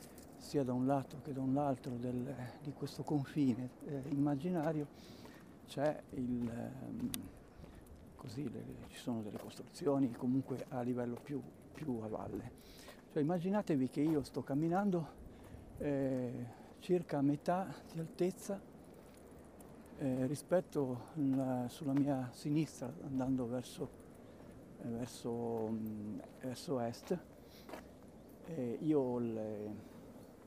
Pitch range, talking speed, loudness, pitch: 125-150 Hz, 115 wpm, -39 LUFS, 135 Hz